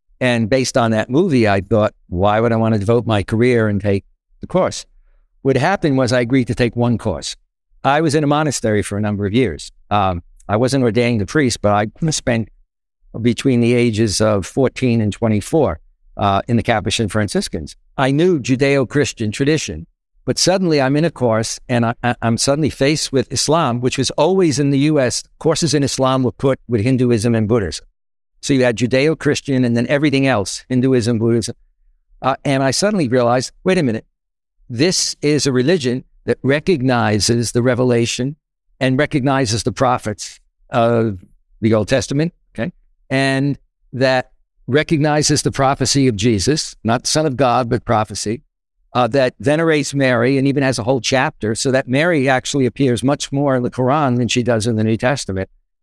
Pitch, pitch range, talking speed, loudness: 125 Hz, 115-140 Hz, 175 wpm, -17 LUFS